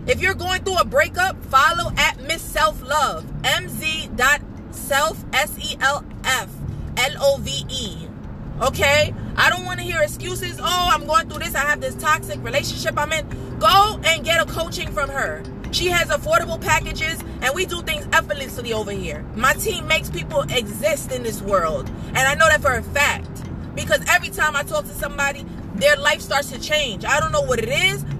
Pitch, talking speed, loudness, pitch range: 310 Hz, 180 wpm, -20 LUFS, 295-335 Hz